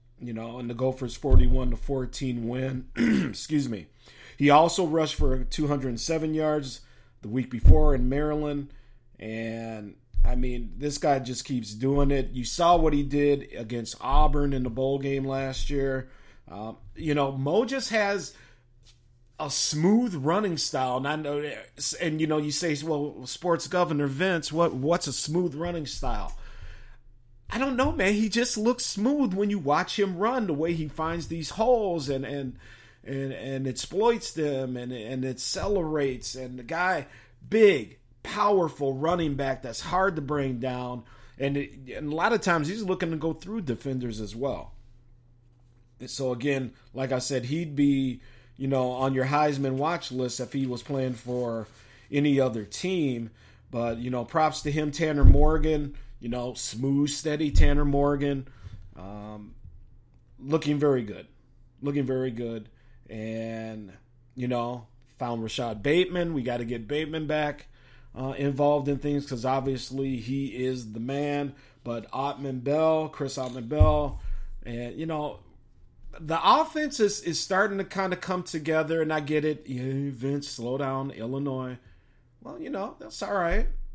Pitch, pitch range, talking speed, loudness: 135 Hz, 125-155 Hz, 165 wpm, -27 LUFS